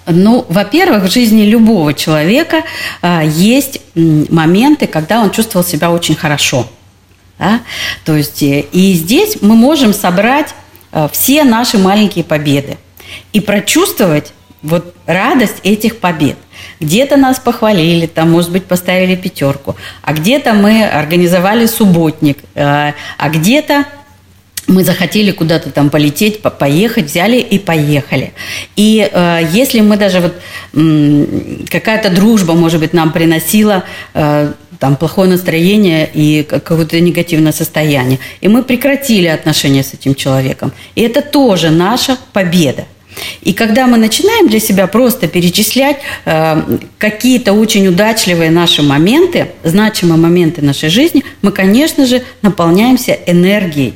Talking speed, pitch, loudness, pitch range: 125 wpm, 180 Hz, -10 LUFS, 155-220 Hz